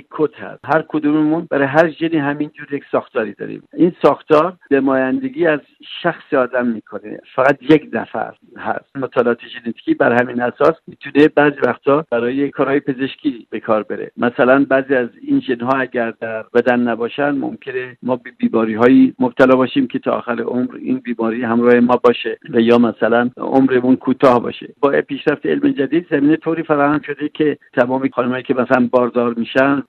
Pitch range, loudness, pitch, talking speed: 125-155 Hz, -16 LUFS, 135 Hz, 165 wpm